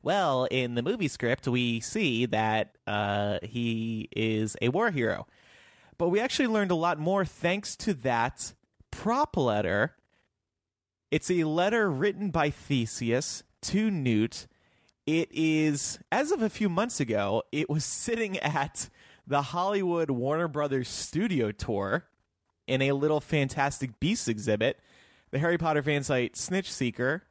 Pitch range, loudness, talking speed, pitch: 115-175 Hz, -28 LUFS, 140 wpm, 135 Hz